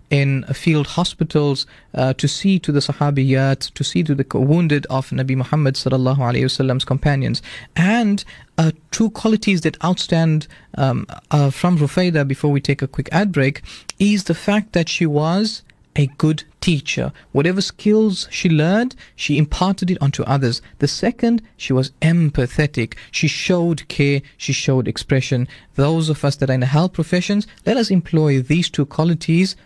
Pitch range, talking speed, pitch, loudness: 135-175 Hz, 165 wpm, 150 Hz, -18 LUFS